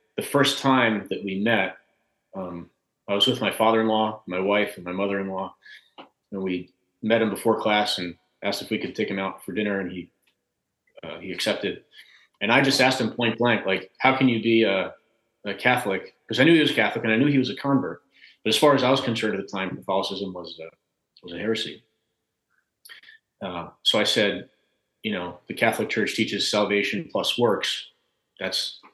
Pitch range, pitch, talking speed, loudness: 95-120 Hz, 110 Hz, 200 wpm, -23 LUFS